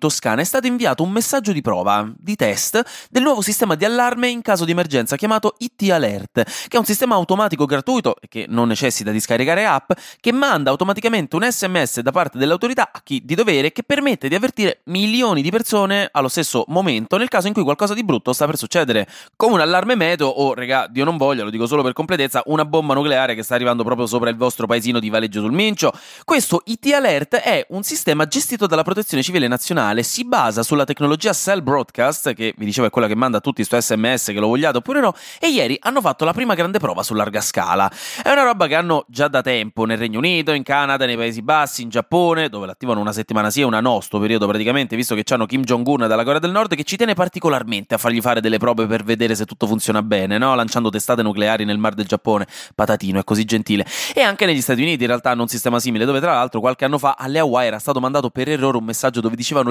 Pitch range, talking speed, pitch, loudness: 115-185 Hz, 235 wpm, 140 Hz, -18 LUFS